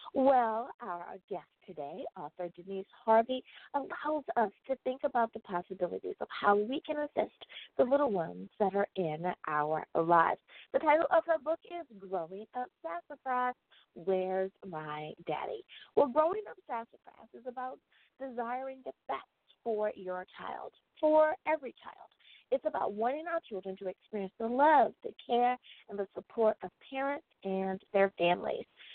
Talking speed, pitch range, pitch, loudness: 150 wpm, 190-290 Hz, 235 Hz, -33 LUFS